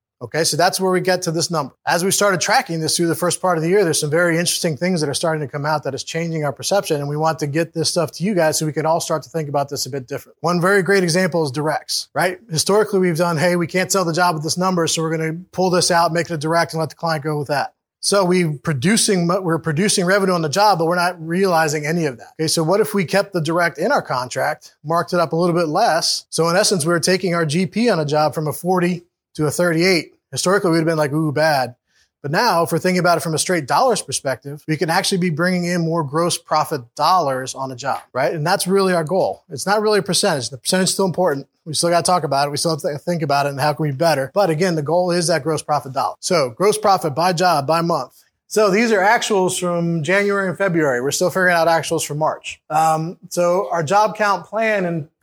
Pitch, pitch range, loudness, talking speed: 170 Hz, 155-185 Hz, -18 LUFS, 275 wpm